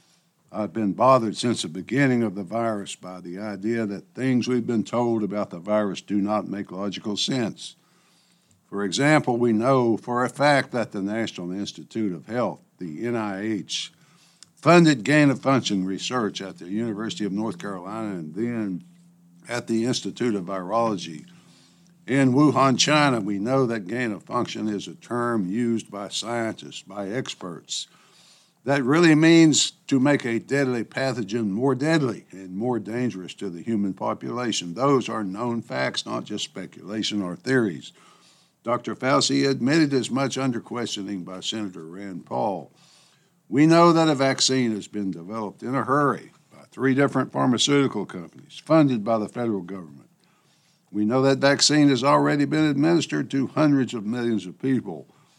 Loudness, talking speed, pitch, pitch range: -23 LUFS, 160 wpm, 120 Hz, 105-135 Hz